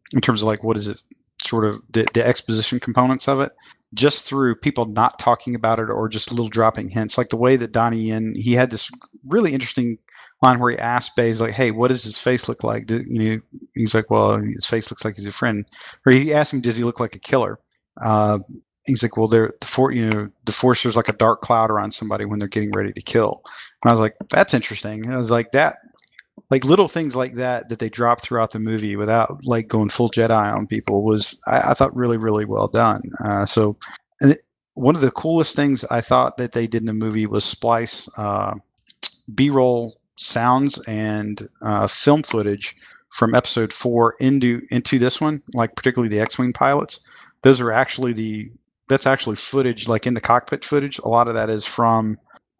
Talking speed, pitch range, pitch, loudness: 220 wpm, 110-125 Hz, 115 Hz, -20 LUFS